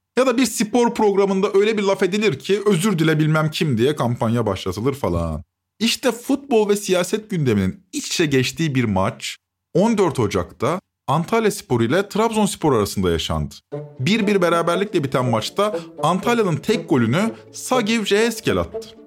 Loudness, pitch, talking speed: -20 LUFS, 180 Hz, 145 wpm